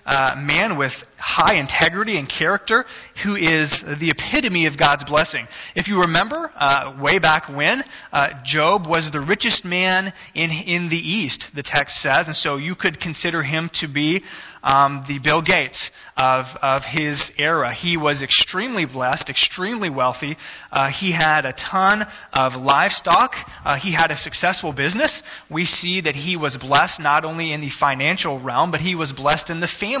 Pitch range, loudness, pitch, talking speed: 145-180 Hz, -18 LUFS, 160 Hz, 180 wpm